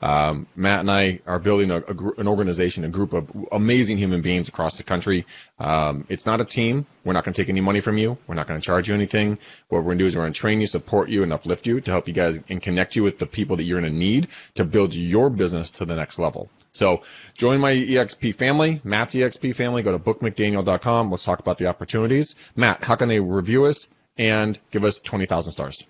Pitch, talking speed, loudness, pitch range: 100 Hz, 250 wpm, -22 LUFS, 90-110 Hz